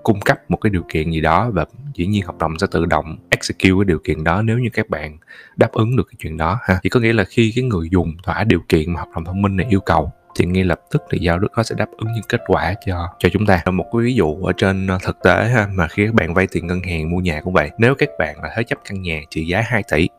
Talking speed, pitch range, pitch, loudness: 305 wpm, 85-110 Hz, 95 Hz, -18 LUFS